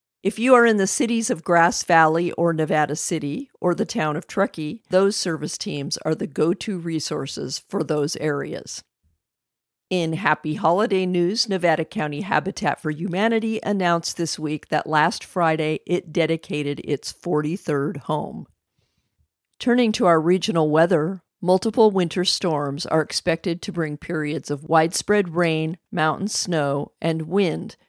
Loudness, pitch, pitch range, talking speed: -22 LUFS, 170 Hz, 155-190 Hz, 145 wpm